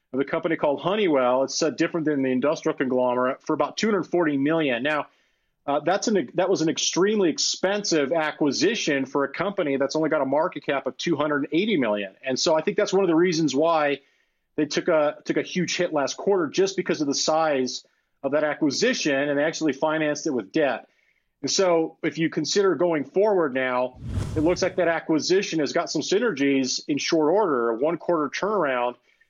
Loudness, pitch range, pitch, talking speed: -23 LUFS, 140-175 Hz, 155 Hz, 195 wpm